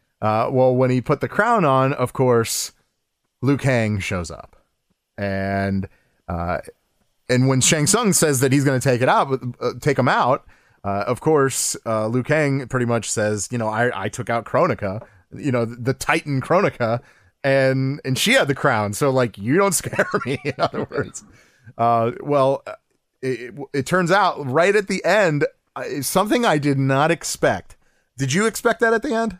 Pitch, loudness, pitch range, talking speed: 130 Hz, -20 LUFS, 115-150 Hz, 185 wpm